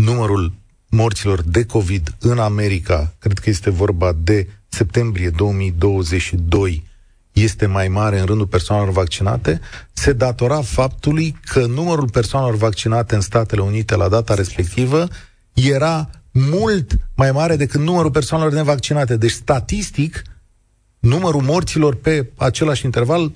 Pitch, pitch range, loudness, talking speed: 115 Hz, 100-140 Hz, -17 LUFS, 125 wpm